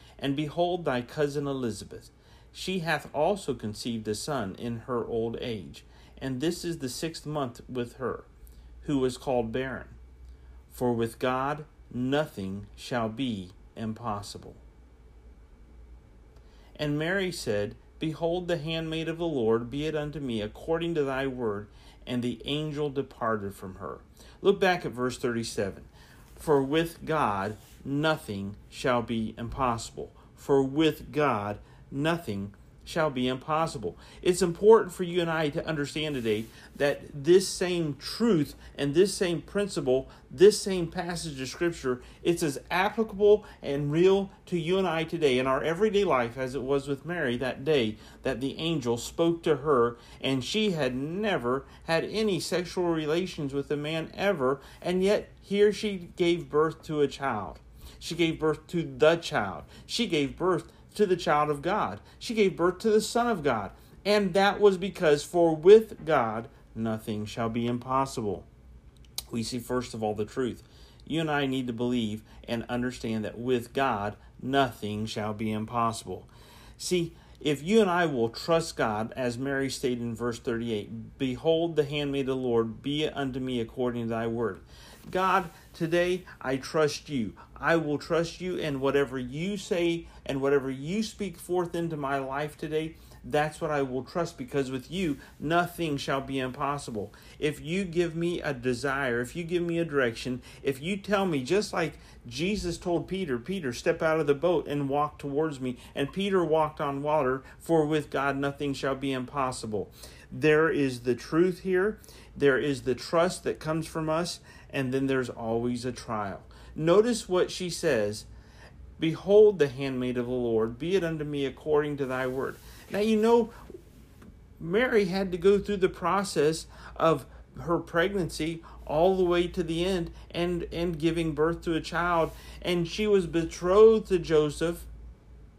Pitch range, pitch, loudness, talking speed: 120-170 Hz, 145 Hz, -28 LUFS, 165 wpm